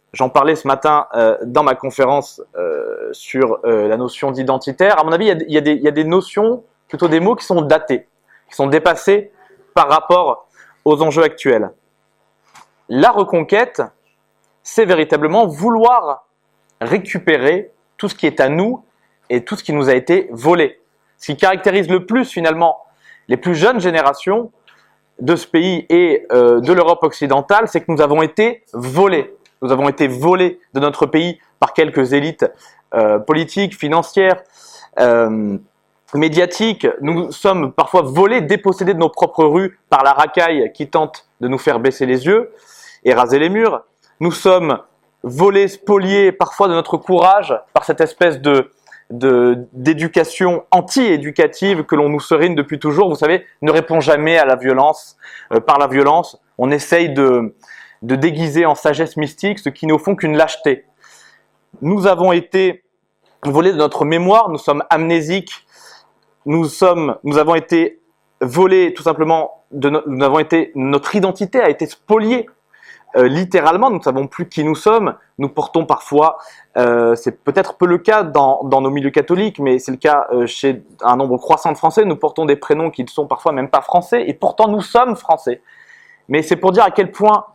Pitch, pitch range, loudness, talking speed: 165 Hz, 145-195 Hz, -14 LUFS, 175 wpm